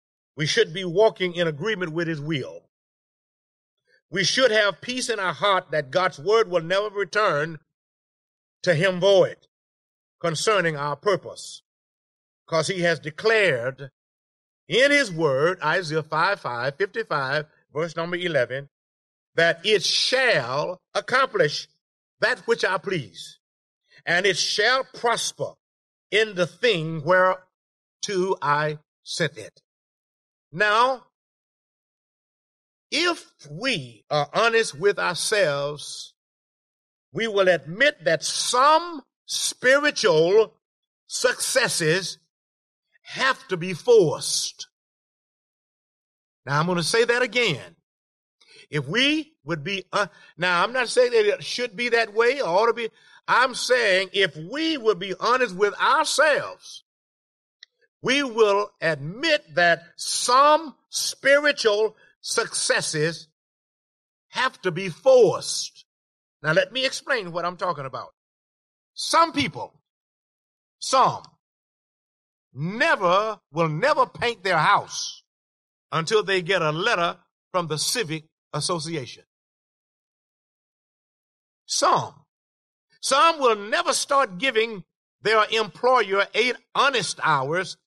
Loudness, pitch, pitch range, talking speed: -22 LUFS, 195 Hz, 160-255 Hz, 110 wpm